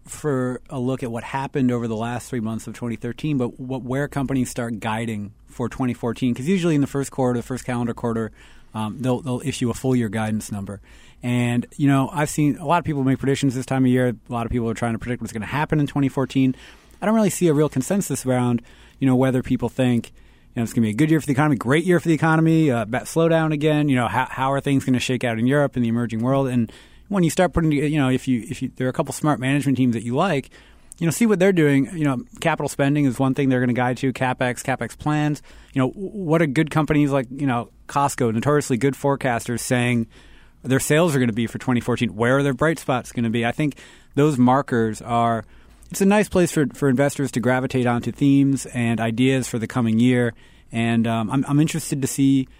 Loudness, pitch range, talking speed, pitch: -21 LUFS, 120-145 Hz, 250 wpm, 130 Hz